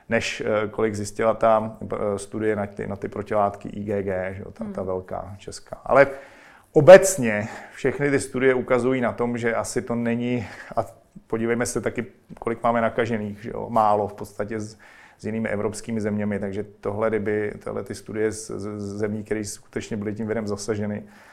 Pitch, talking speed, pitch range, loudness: 110 Hz, 170 wpm, 105-115 Hz, -23 LUFS